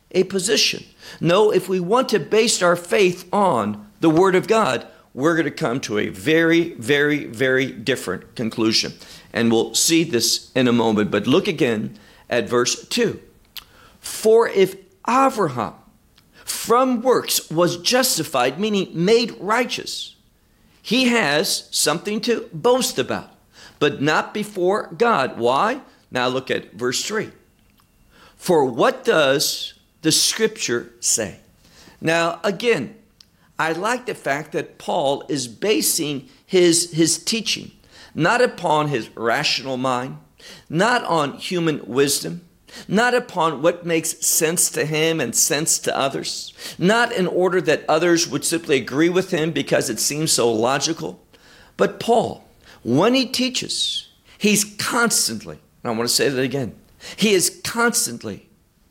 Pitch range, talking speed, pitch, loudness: 140-210 Hz, 140 wpm, 170 Hz, -19 LUFS